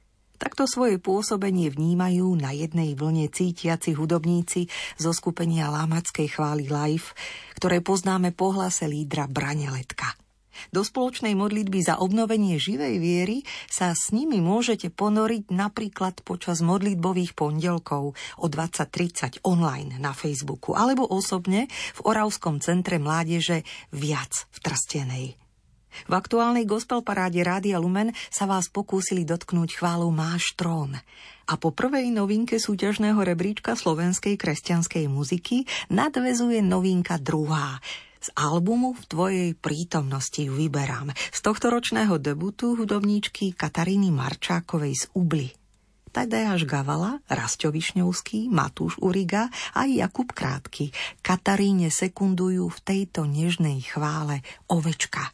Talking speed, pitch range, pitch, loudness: 115 wpm, 155-200 Hz, 175 Hz, -25 LUFS